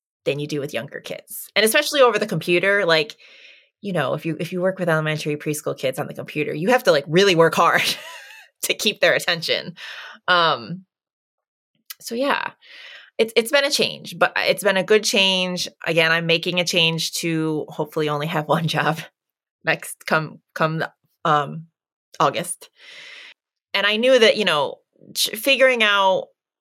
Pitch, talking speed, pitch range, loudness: 180 Hz, 170 wpm, 160-225 Hz, -20 LUFS